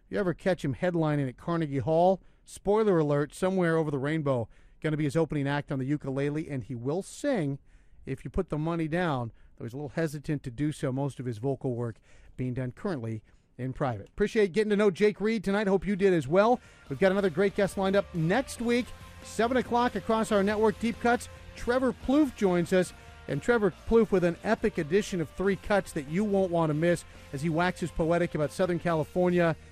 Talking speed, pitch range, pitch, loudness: 215 wpm, 145-200 Hz, 175 Hz, -28 LUFS